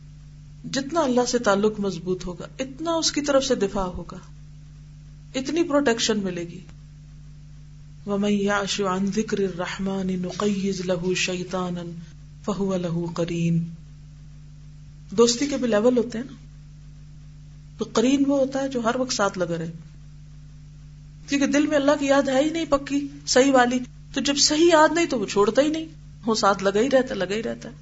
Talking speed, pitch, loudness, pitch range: 160 wpm, 190 Hz, -23 LUFS, 150-250 Hz